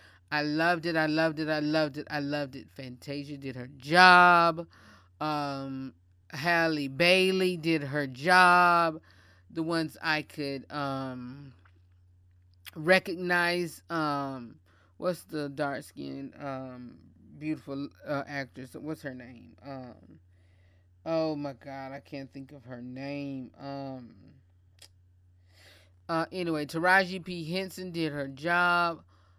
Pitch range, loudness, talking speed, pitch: 115-160 Hz, -27 LUFS, 120 wpm, 140 Hz